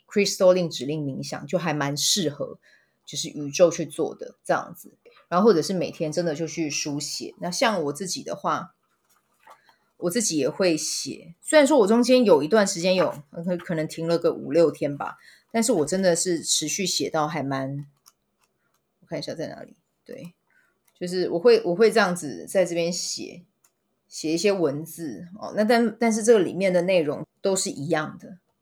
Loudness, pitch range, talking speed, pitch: -23 LUFS, 155-205 Hz, 275 characters per minute, 175 Hz